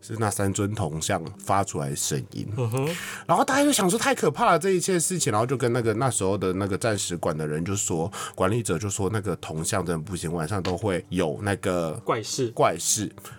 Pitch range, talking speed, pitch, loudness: 90-120 Hz, 315 characters per minute, 100 Hz, -25 LUFS